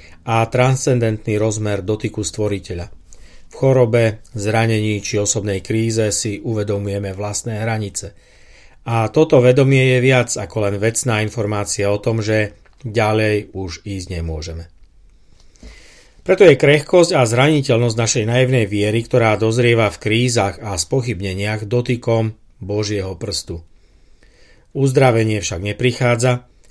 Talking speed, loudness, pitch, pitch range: 115 wpm, -17 LUFS, 110 Hz, 100-120 Hz